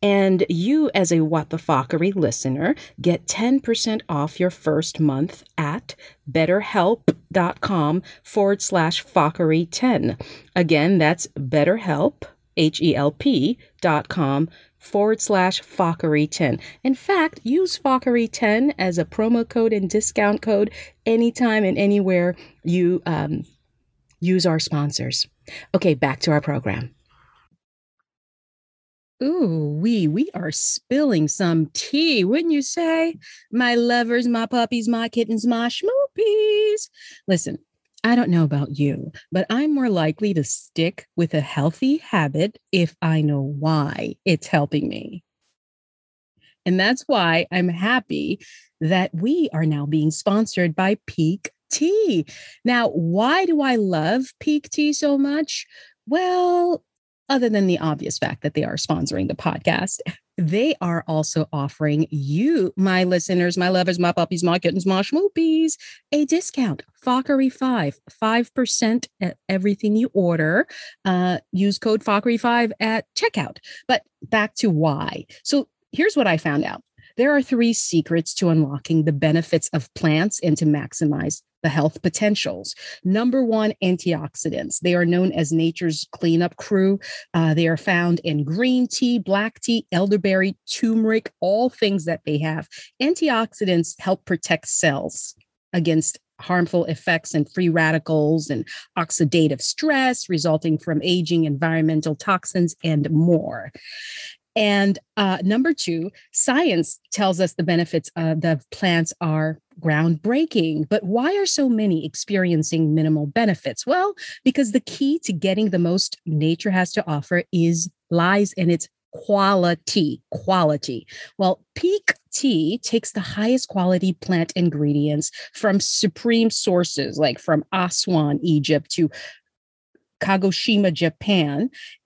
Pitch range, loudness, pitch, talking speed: 160-230 Hz, -21 LUFS, 185 Hz, 135 wpm